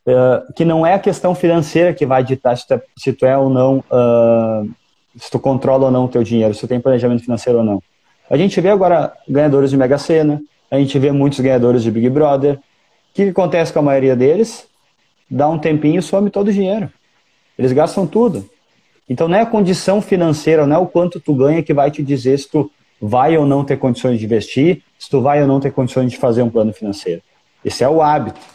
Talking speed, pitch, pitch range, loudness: 230 wpm, 140 Hz, 125-165 Hz, -14 LUFS